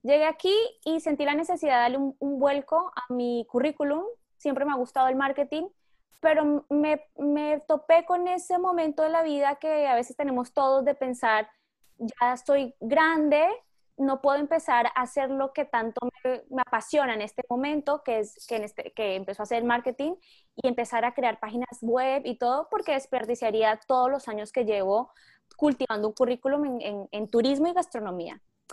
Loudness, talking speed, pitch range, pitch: -26 LUFS, 185 wpm, 240-300 Hz, 270 Hz